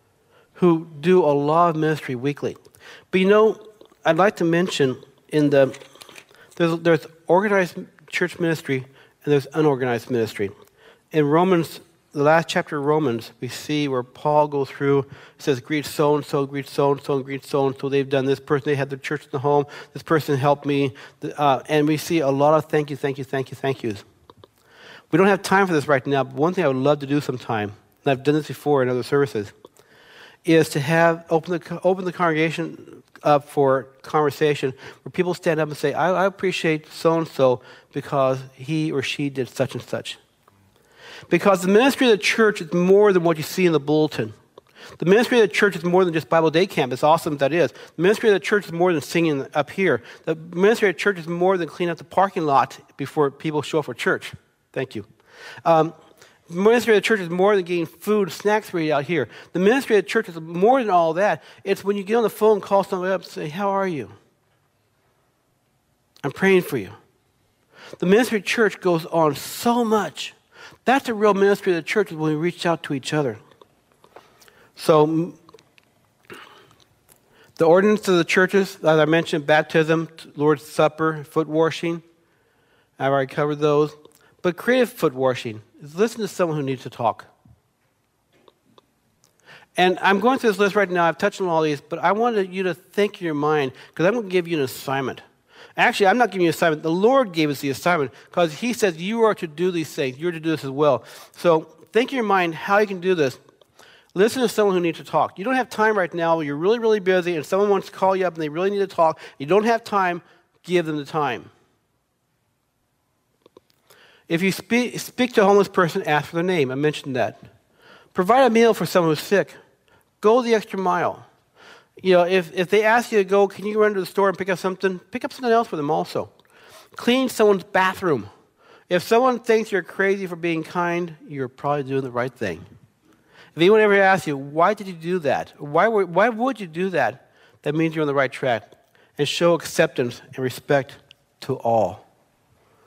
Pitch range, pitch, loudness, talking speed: 145-195 Hz, 165 Hz, -21 LUFS, 210 wpm